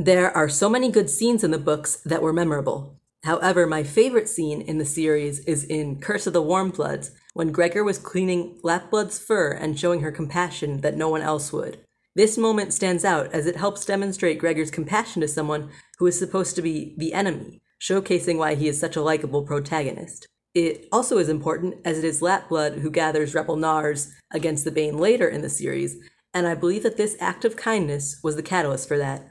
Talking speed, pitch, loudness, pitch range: 205 wpm, 165 Hz, -23 LUFS, 155-185 Hz